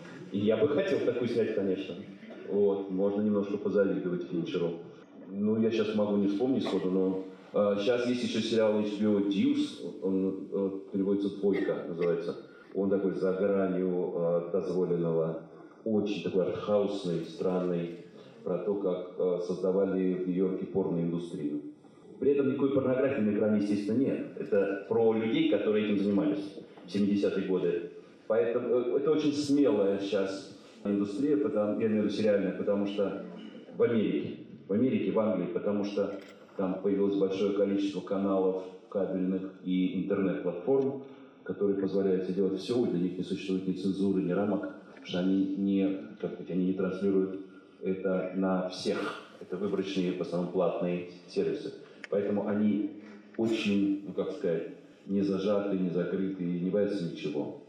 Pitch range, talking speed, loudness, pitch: 95-105 Hz, 145 wpm, -30 LUFS, 100 Hz